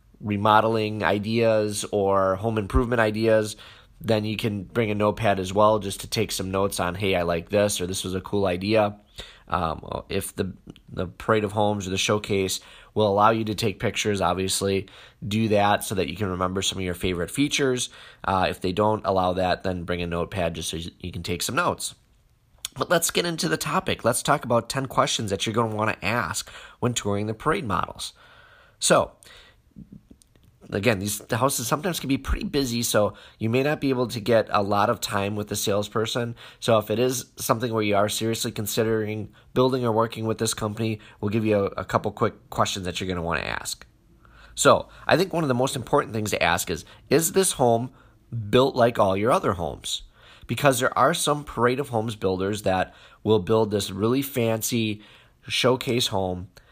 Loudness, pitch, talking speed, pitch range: -24 LUFS, 110 Hz, 200 wpm, 100-120 Hz